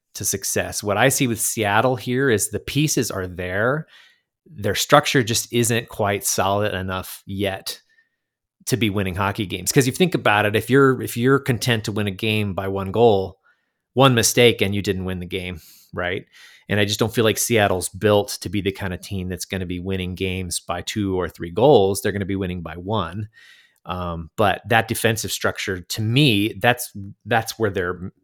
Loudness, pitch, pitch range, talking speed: -20 LUFS, 105 Hz, 95-115 Hz, 200 wpm